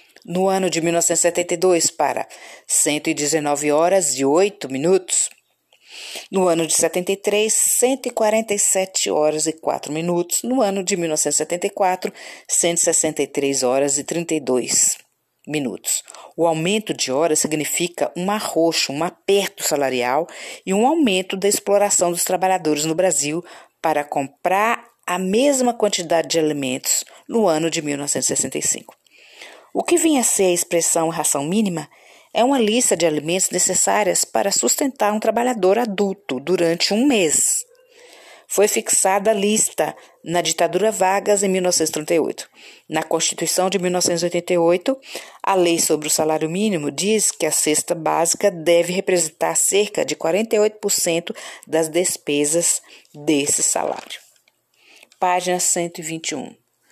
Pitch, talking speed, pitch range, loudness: 175 Hz, 120 wpm, 160-200 Hz, -19 LUFS